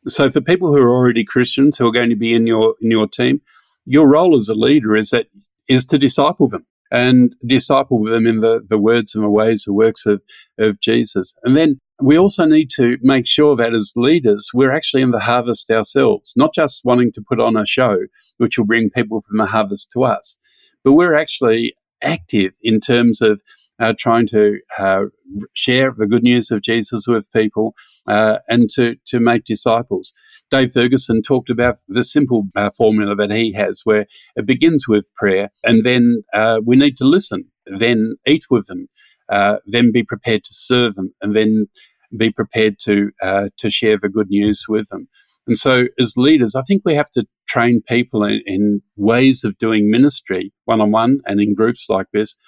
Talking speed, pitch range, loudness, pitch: 200 wpm, 110-125 Hz, -15 LUFS, 115 Hz